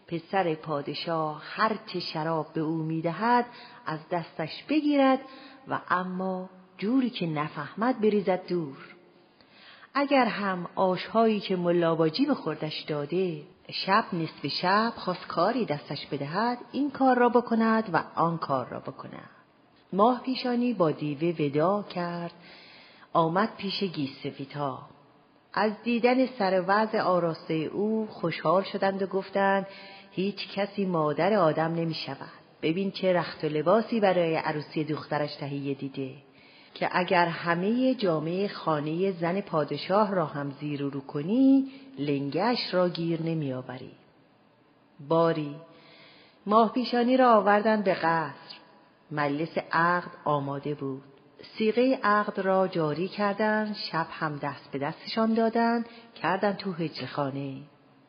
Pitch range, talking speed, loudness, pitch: 155-210 Hz, 125 wpm, -27 LUFS, 175 Hz